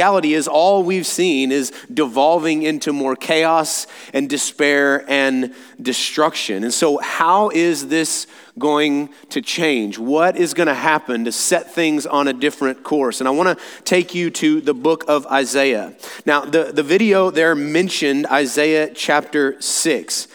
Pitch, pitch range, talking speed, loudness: 150 Hz, 140-165 Hz, 160 wpm, -17 LUFS